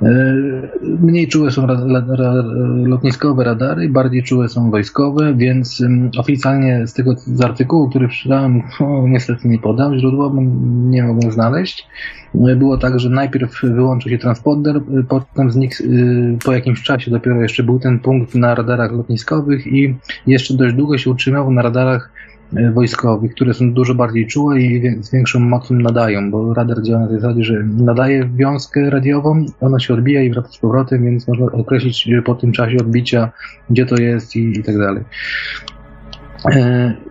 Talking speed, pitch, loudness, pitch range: 165 wpm, 125 Hz, -14 LUFS, 120-135 Hz